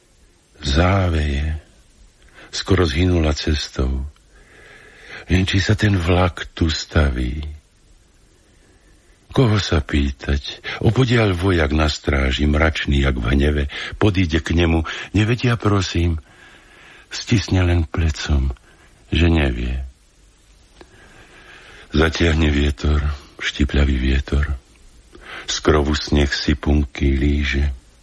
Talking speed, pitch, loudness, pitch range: 90 wpm, 75 Hz, -19 LUFS, 70-90 Hz